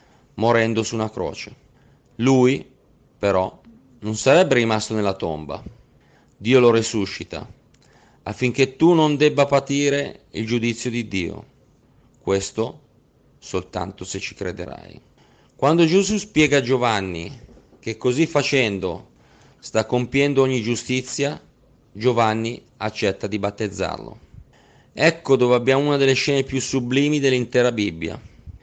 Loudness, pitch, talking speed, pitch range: -20 LUFS, 125 Hz, 115 wpm, 105-135 Hz